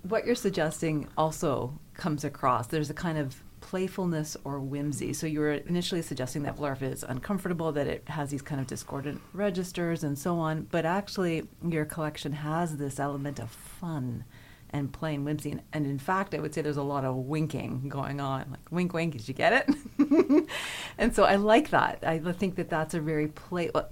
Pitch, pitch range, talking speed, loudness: 155 Hz, 140-175 Hz, 195 wpm, -30 LUFS